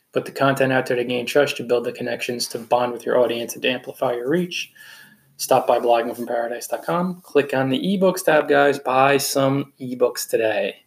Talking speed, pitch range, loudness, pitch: 195 wpm, 120-140 Hz, -21 LUFS, 130 Hz